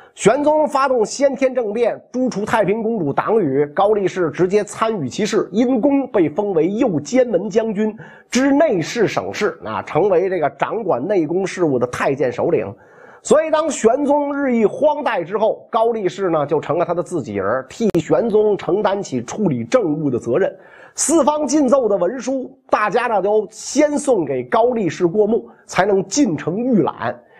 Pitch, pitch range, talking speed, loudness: 225 Hz, 195-275 Hz, 260 characters per minute, -18 LUFS